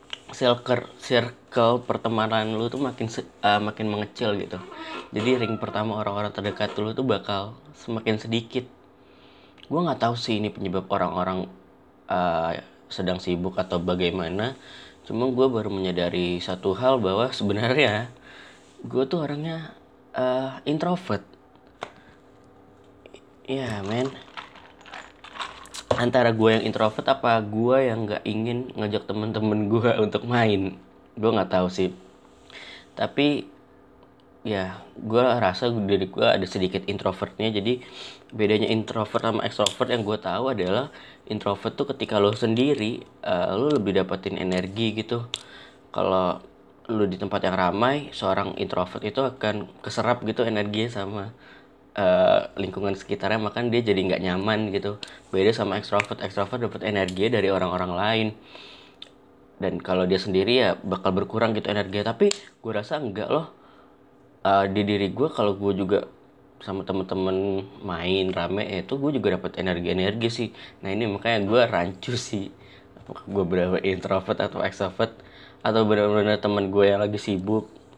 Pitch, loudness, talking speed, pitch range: 105 Hz, -25 LUFS, 140 wpm, 95-115 Hz